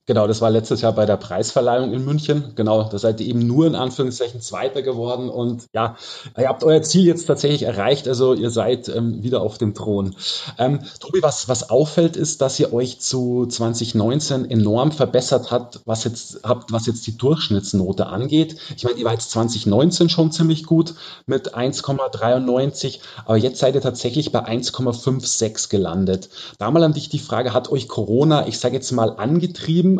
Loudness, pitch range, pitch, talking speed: -19 LUFS, 115-145 Hz, 125 Hz, 180 wpm